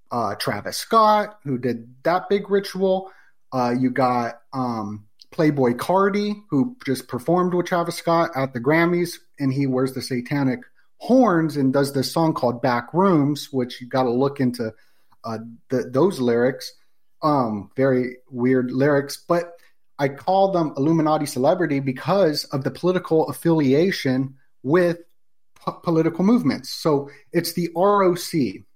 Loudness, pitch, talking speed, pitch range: -21 LUFS, 145 Hz, 145 wpm, 130-175 Hz